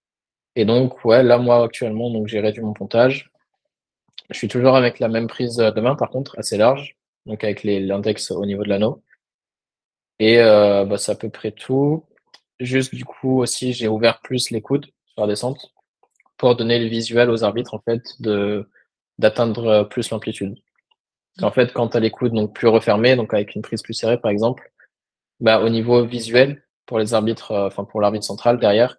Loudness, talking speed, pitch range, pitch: -19 LUFS, 195 wpm, 105-125 Hz, 115 Hz